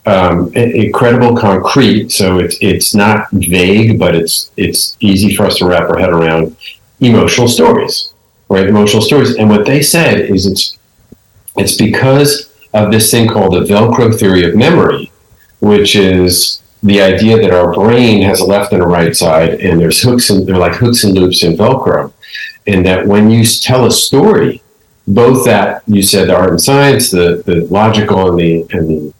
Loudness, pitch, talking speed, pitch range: -8 LUFS, 105 Hz, 180 wpm, 95-115 Hz